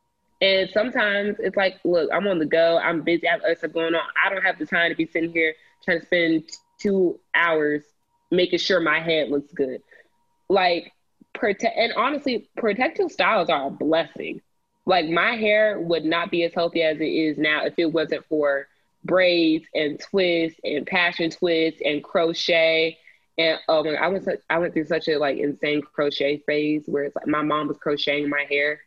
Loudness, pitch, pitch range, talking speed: -22 LUFS, 165 Hz, 155-185 Hz, 200 wpm